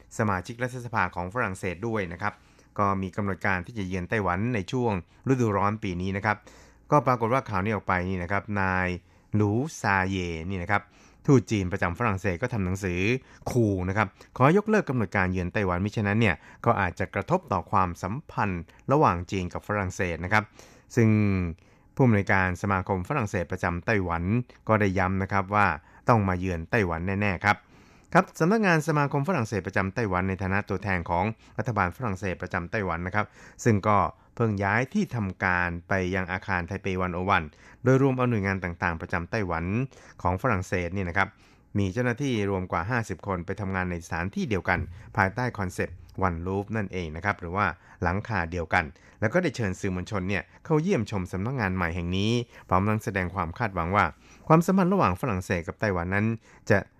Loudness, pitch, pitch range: -27 LUFS, 100 Hz, 90-115 Hz